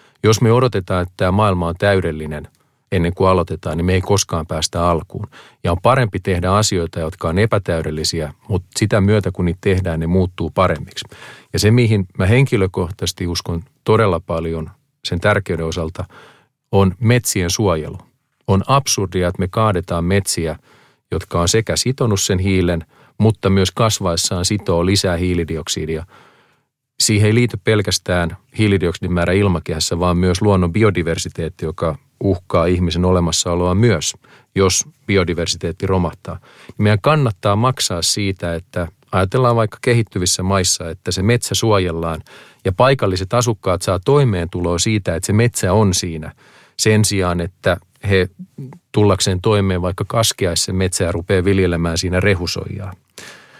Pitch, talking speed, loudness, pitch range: 95 Hz, 140 wpm, -17 LUFS, 85-105 Hz